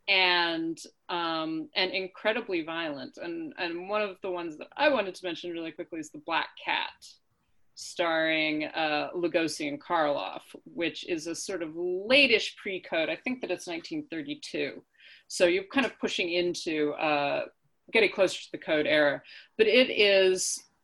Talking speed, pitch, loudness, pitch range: 160 wpm, 180 Hz, -28 LUFS, 165-240 Hz